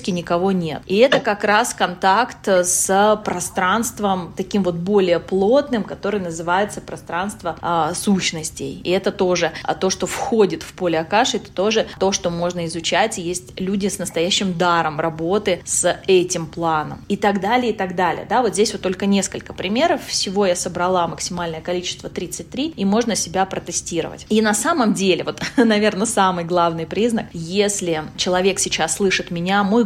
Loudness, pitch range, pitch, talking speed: -19 LUFS, 175-205 Hz, 185 Hz, 165 wpm